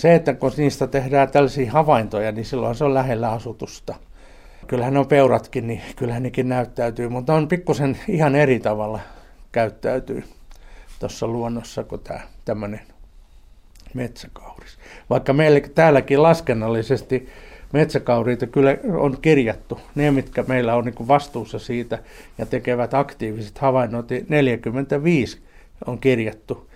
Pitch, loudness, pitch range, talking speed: 125 Hz, -20 LUFS, 115-140 Hz, 120 wpm